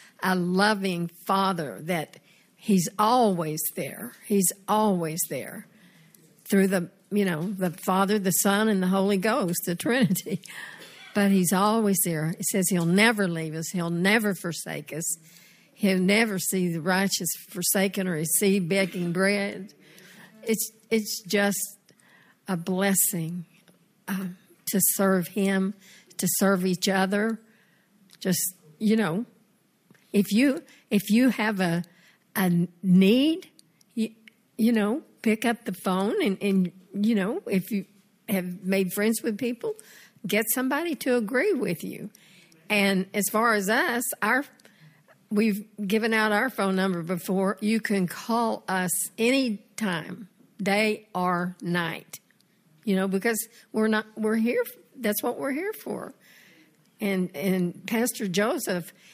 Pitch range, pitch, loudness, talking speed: 185-215 Hz, 195 Hz, -25 LUFS, 135 wpm